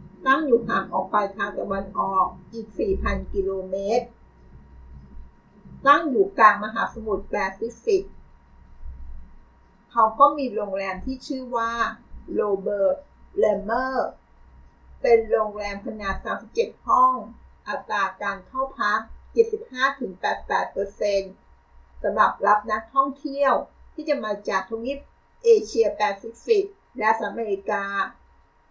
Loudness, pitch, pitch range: -24 LUFS, 210 Hz, 190-260 Hz